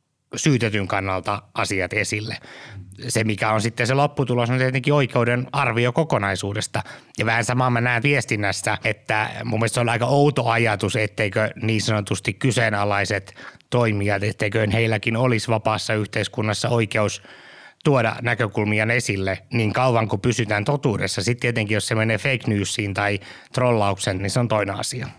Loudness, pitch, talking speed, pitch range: -21 LUFS, 110 Hz, 150 wpm, 105-125 Hz